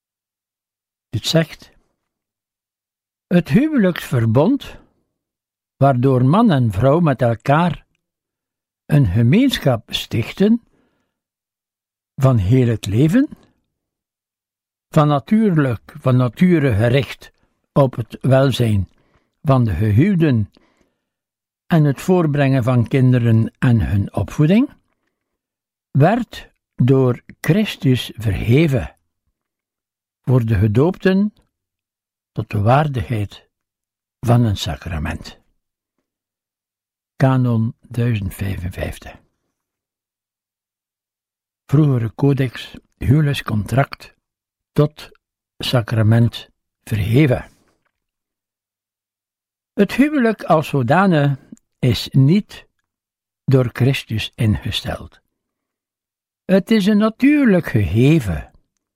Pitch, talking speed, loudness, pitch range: 120 Hz, 70 wpm, -17 LUFS, 100-145 Hz